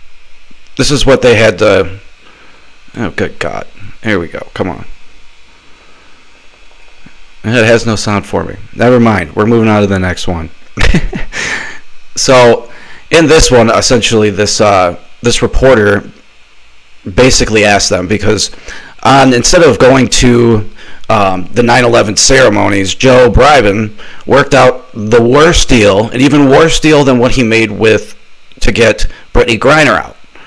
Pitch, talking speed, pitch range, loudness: 110 Hz, 140 wpm, 100-125 Hz, -8 LUFS